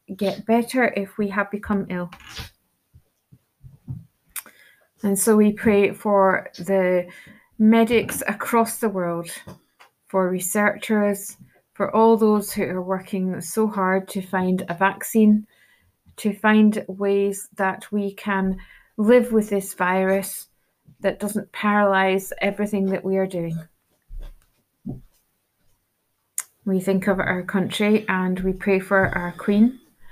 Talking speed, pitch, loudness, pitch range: 120 wpm, 200 Hz, -21 LUFS, 190-210 Hz